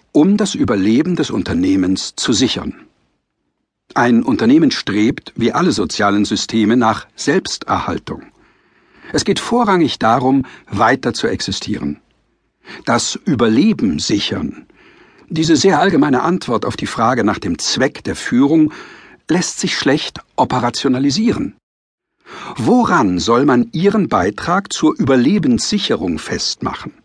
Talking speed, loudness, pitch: 110 wpm, -15 LUFS, 160 Hz